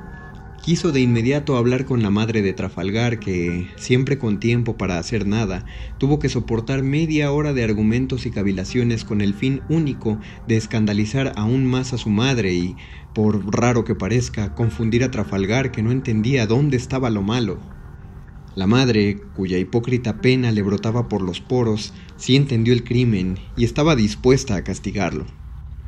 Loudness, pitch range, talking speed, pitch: -20 LUFS, 100-125 Hz, 160 wpm, 115 Hz